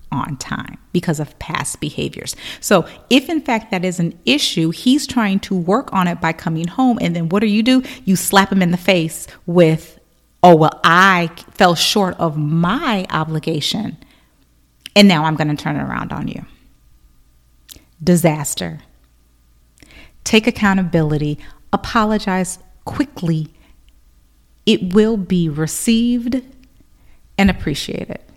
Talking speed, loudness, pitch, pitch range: 135 wpm, -16 LUFS, 175 Hz, 155-210 Hz